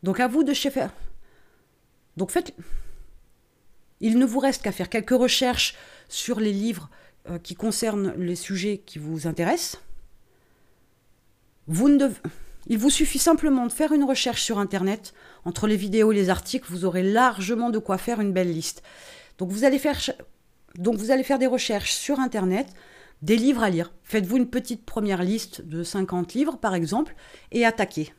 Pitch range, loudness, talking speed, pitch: 180-255 Hz, -24 LUFS, 160 wpm, 215 Hz